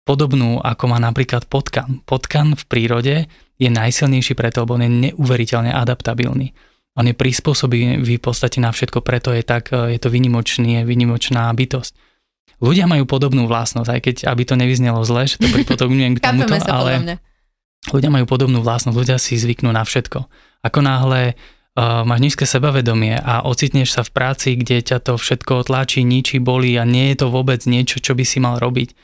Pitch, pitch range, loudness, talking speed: 125 Hz, 120-130 Hz, -16 LUFS, 180 wpm